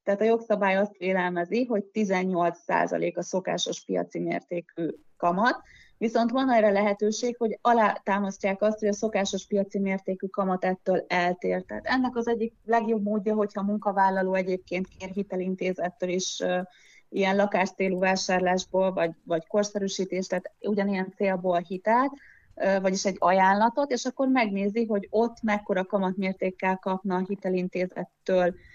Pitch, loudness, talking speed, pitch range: 195 Hz, -27 LUFS, 135 wpm, 185-210 Hz